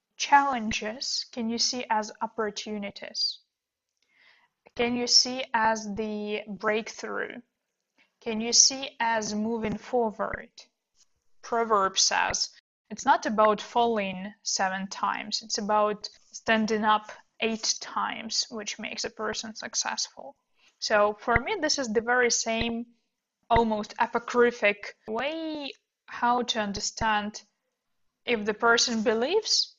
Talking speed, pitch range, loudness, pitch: 110 wpm, 215-240 Hz, -26 LUFS, 225 Hz